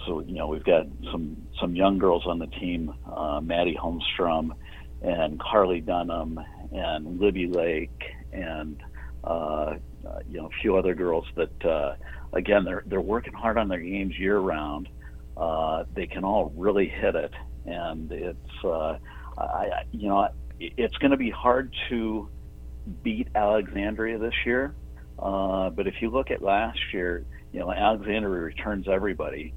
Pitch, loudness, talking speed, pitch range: 85 Hz, -27 LUFS, 160 wpm, 60-100 Hz